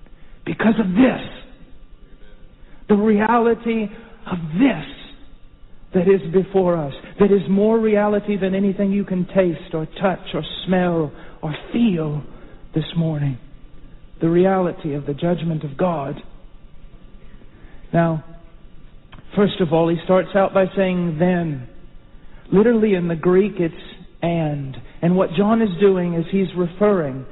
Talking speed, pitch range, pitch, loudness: 130 wpm, 165-200 Hz, 180 Hz, -19 LUFS